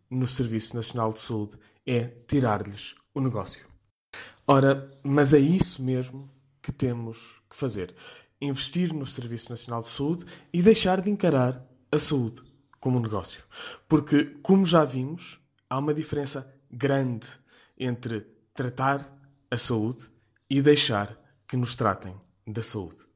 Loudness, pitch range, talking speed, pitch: -26 LUFS, 115-145 Hz, 135 wpm, 130 Hz